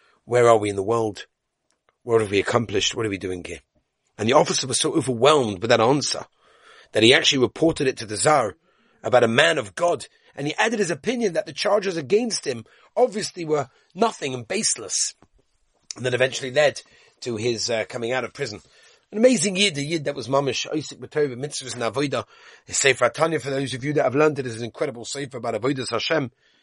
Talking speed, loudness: 215 wpm, -22 LUFS